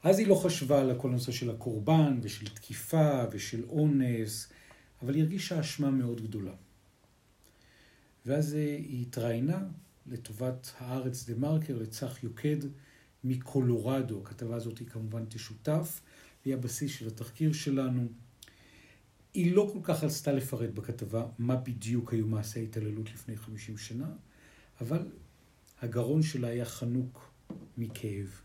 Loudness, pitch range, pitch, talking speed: -33 LUFS, 115-145 Hz, 125 Hz, 125 wpm